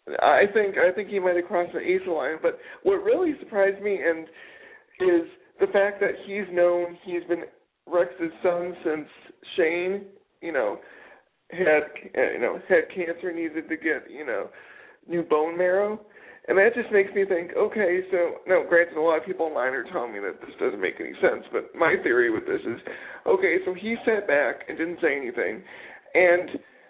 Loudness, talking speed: -25 LUFS, 185 wpm